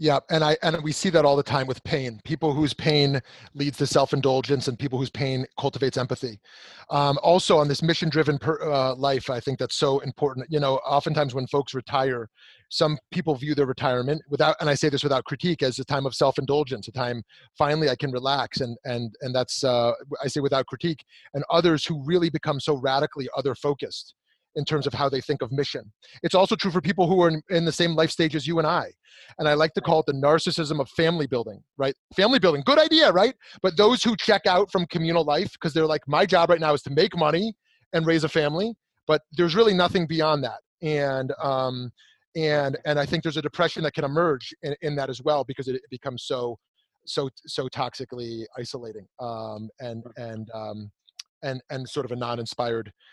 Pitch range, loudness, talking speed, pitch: 130-160 Hz, -24 LUFS, 215 wpm, 145 Hz